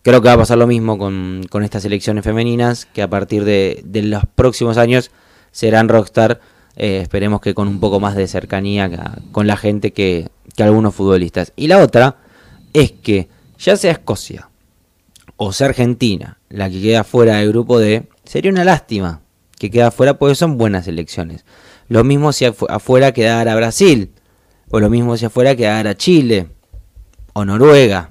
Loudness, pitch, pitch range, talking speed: -14 LUFS, 105 Hz, 100-120 Hz, 175 wpm